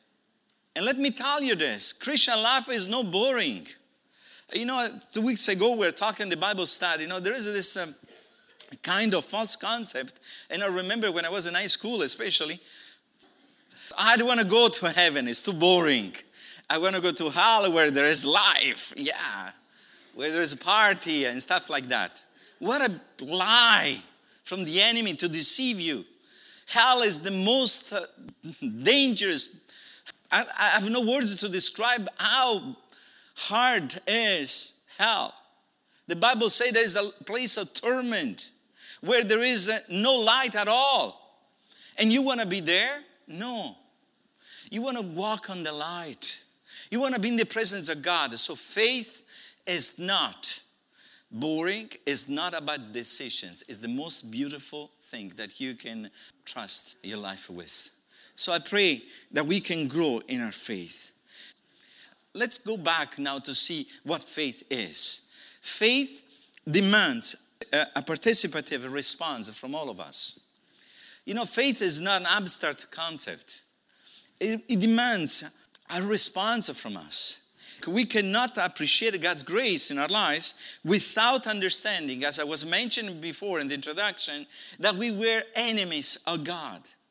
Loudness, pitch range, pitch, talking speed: -24 LUFS, 165-235 Hz, 205 Hz, 155 wpm